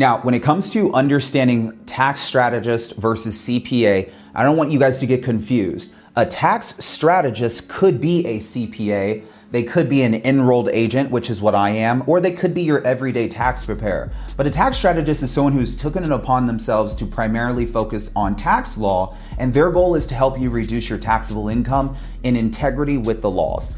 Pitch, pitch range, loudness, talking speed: 125 Hz, 115-140 Hz, -19 LUFS, 195 wpm